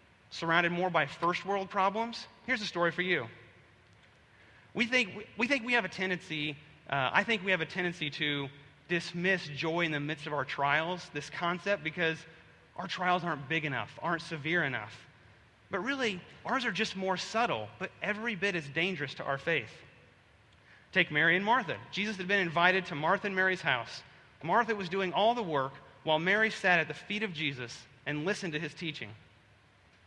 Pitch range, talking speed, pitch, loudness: 145-195 Hz, 185 wpm, 170 Hz, -31 LUFS